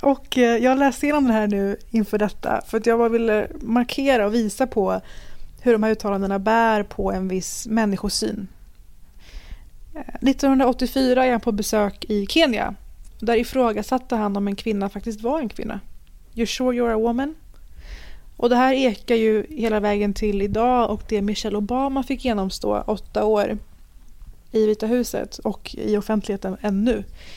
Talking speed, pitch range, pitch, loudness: 160 wpm, 205-245 Hz, 220 Hz, -21 LUFS